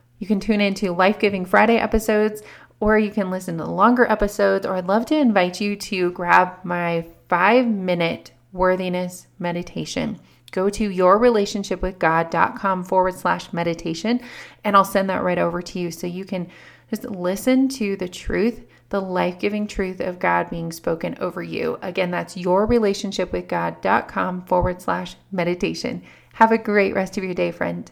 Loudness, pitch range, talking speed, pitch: -21 LUFS, 180-210 Hz, 170 wpm, 185 Hz